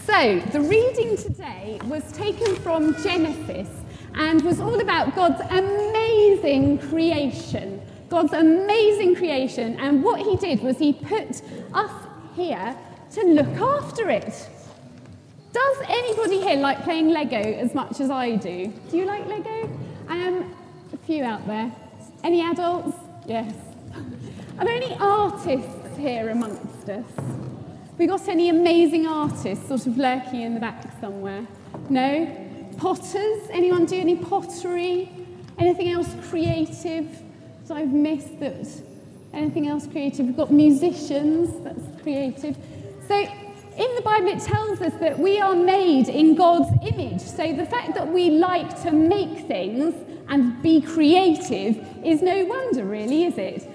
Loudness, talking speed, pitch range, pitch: -22 LUFS, 140 wpm, 280-365 Hz, 330 Hz